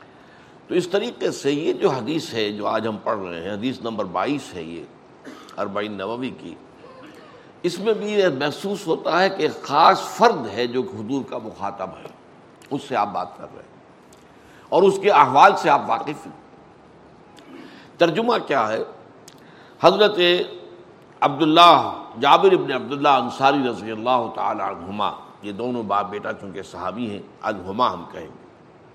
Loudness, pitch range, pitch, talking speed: -20 LUFS, 105-170 Hz, 130 Hz, 160 wpm